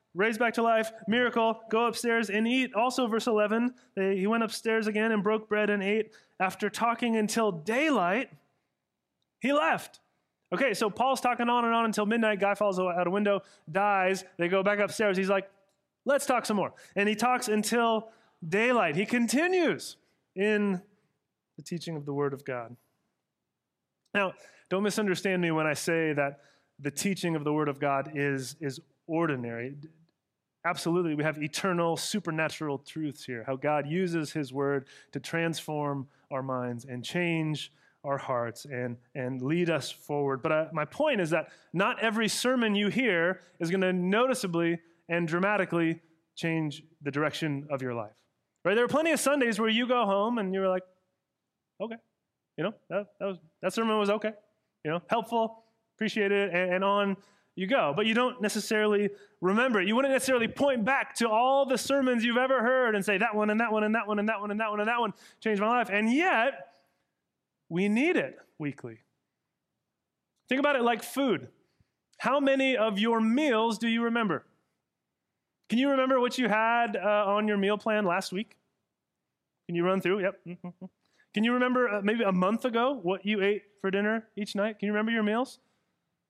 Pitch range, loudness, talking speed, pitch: 165-230 Hz, -28 LUFS, 185 wpm, 205 Hz